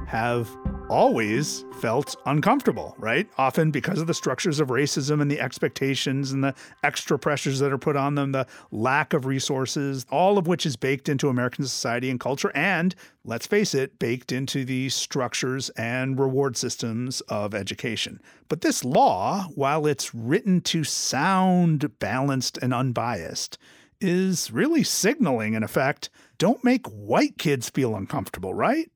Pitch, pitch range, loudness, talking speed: 140 Hz, 125-160 Hz, -24 LUFS, 155 wpm